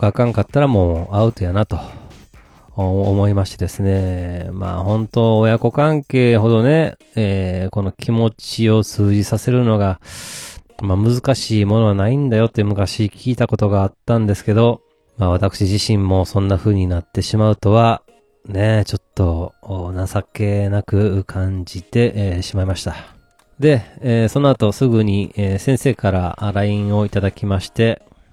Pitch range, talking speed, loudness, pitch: 95-115 Hz, 300 characters per minute, -17 LUFS, 105 Hz